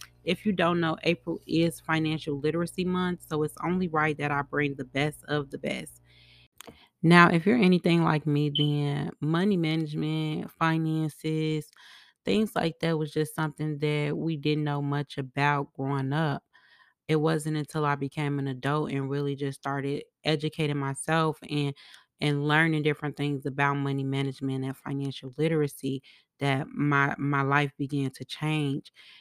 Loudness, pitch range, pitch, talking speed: -28 LUFS, 140-160 Hz, 150 Hz, 155 wpm